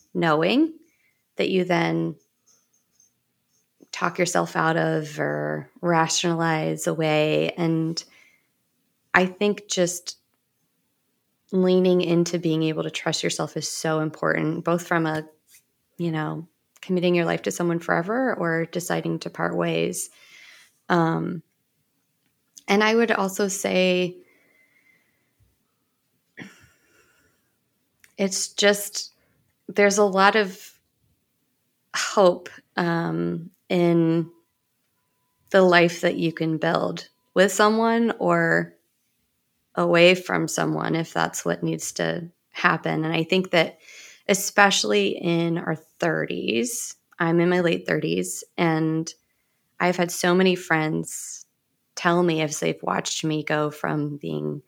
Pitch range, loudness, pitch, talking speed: 150-180 Hz, -23 LUFS, 165 Hz, 110 wpm